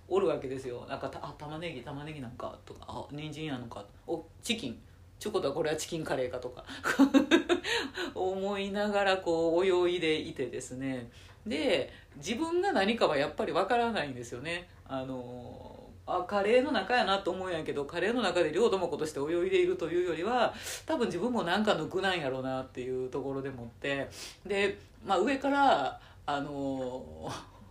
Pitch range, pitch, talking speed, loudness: 130-205 Hz, 165 Hz, 355 characters per minute, -31 LUFS